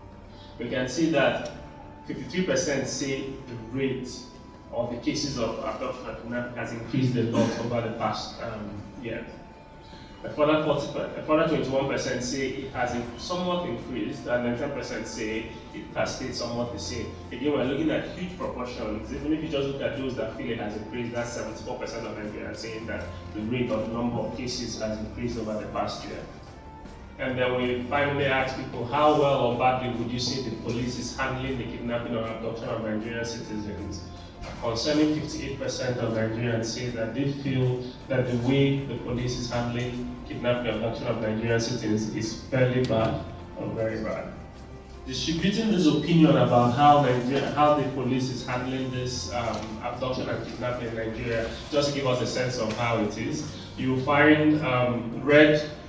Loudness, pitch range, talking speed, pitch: -27 LUFS, 115-135 Hz, 175 wpm, 120 Hz